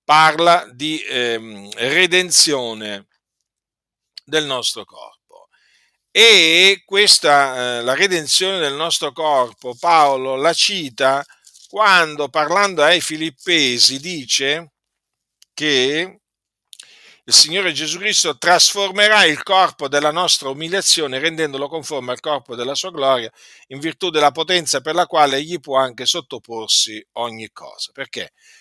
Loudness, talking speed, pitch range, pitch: -15 LUFS, 110 wpm, 130-175 Hz, 150 Hz